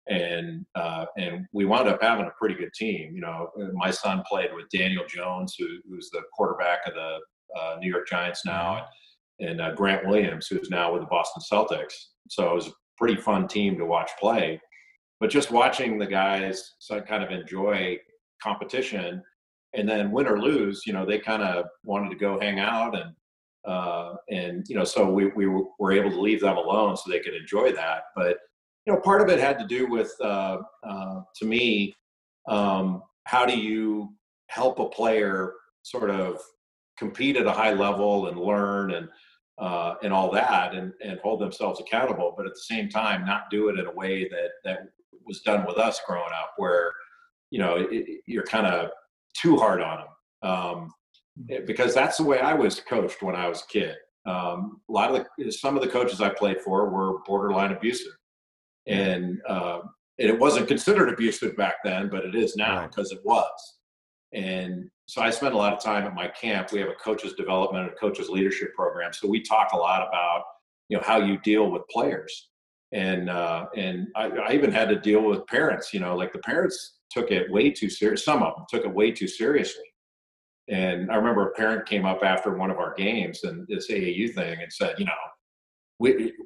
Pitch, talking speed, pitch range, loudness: 100 Hz, 205 wpm, 95-120 Hz, -26 LUFS